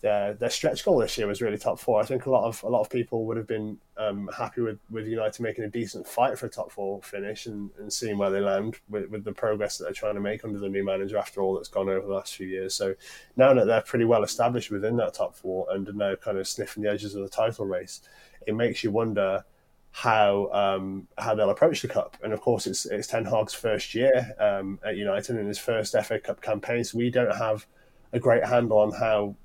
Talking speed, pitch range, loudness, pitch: 255 wpm, 100-115 Hz, -27 LUFS, 105 Hz